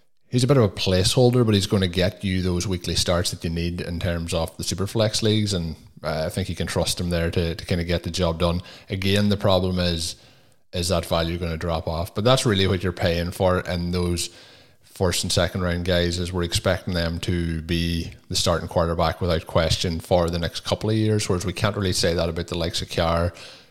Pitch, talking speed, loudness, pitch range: 90 Hz, 240 wpm, -23 LUFS, 85-100 Hz